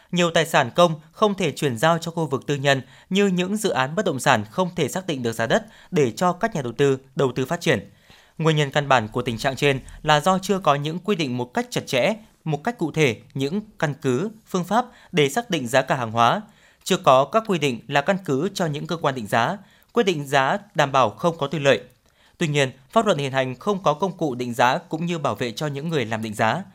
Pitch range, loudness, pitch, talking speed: 135-185 Hz, -22 LUFS, 155 Hz, 260 wpm